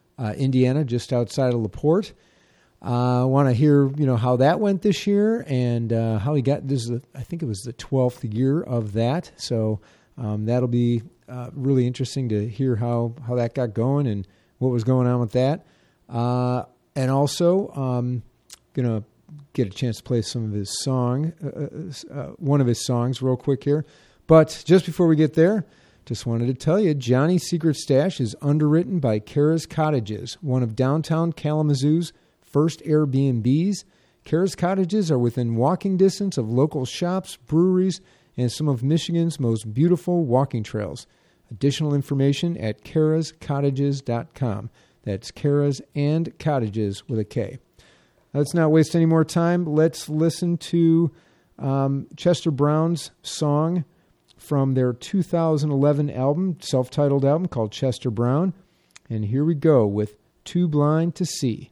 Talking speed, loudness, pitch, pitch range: 165 wpm, -22 LUFS, 140 Hz, 125-160 Hz